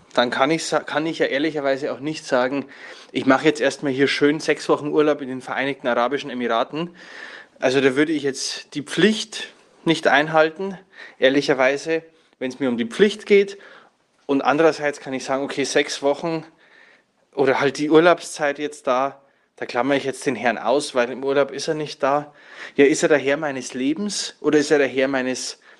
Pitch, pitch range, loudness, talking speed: 145 Hz, 135-155 Hz, -21 LUFS, 190 wpm